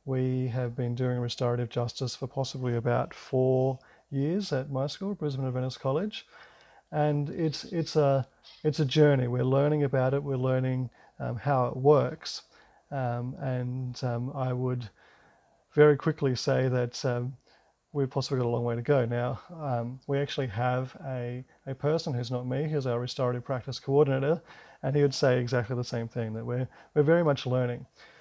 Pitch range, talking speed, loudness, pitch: 125-145 Hz, 175 wpm, -29 LUFS, 130 Hz